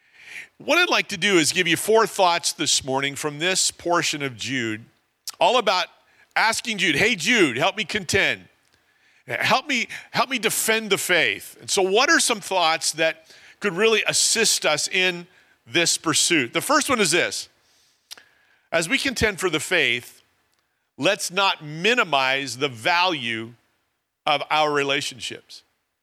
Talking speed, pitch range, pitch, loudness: 150 wpm, 145-220 Hz, 180 Hz, -20 LUFS